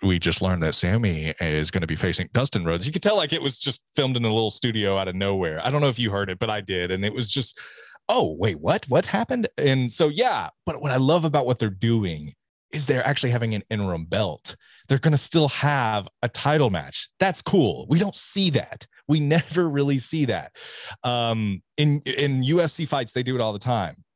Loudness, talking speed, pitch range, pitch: -23 LUFS, 235 wpm, 100-145 Hz, 125 Hz